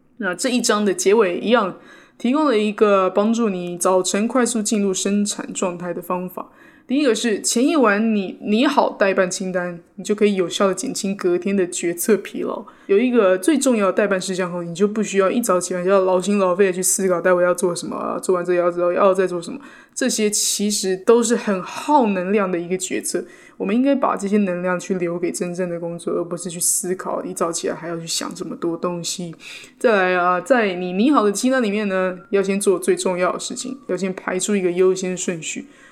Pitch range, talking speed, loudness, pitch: 180-225 Hz, 320 characters per minute, -19 LUFS, 195 Hz